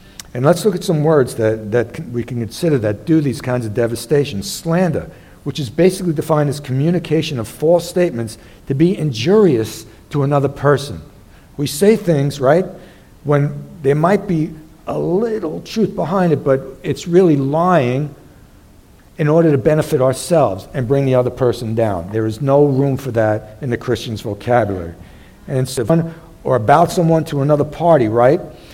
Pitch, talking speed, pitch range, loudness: 140 Hz, 165 wpm, 120-165 Hz, -16 LUFS